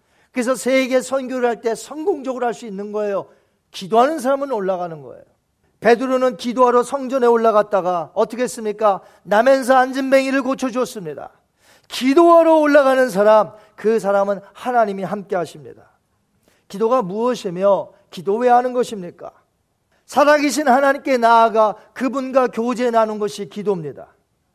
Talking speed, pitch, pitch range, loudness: 340 characters per minute, 235 Hz, 205-260 Hz, -17 LUFS